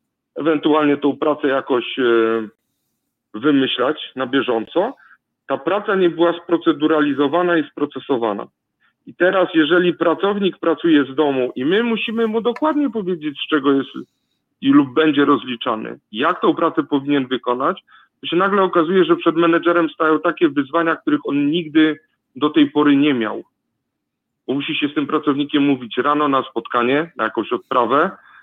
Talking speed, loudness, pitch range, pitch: 150 wpm, -18 LUFS, 145-170 Hz, 155 Hz